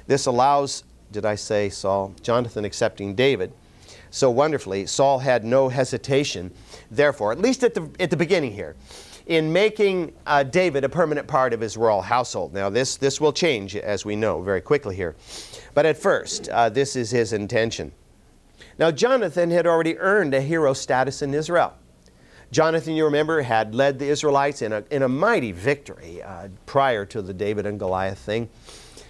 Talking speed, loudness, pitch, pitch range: 175 wpm, -22 LUFS, 135 Hz, 105-150 Hz